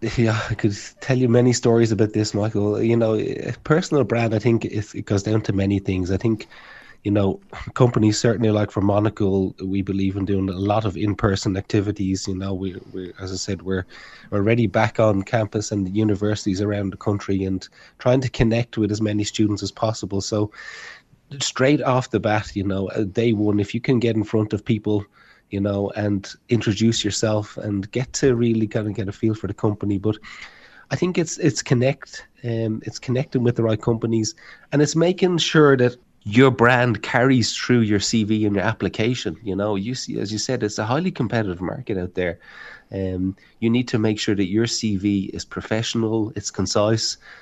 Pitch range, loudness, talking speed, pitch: 100-115 Hz, -21 LUFS, 200 wpm, 110 Hz